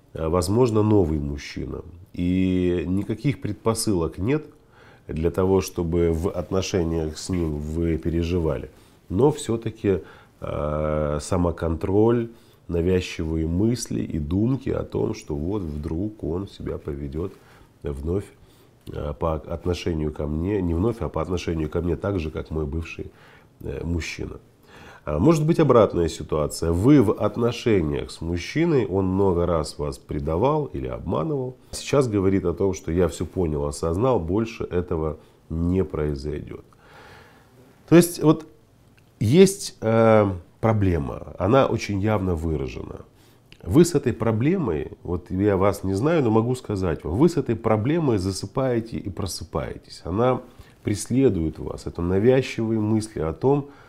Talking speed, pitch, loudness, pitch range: 130 wpm, 95 Hz, -23 LUFS, 85-115 Hz